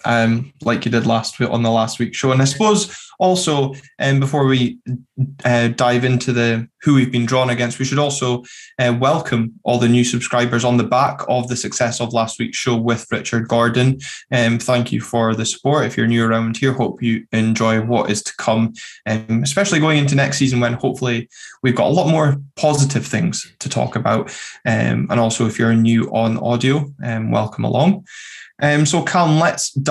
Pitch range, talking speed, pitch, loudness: 115-135 Hz, 205 wpm, 120 Hz, -17 LUFS